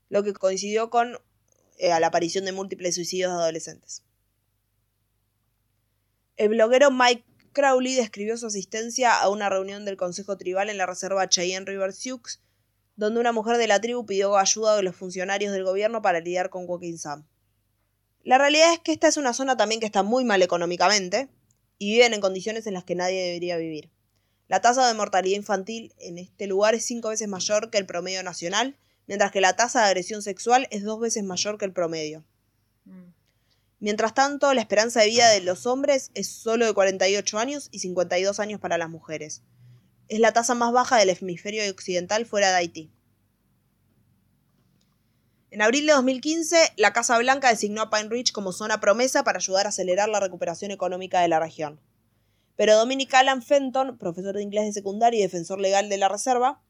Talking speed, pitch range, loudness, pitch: 185 wpm, 175-225 Hz, -23 LUFS, 195 Hz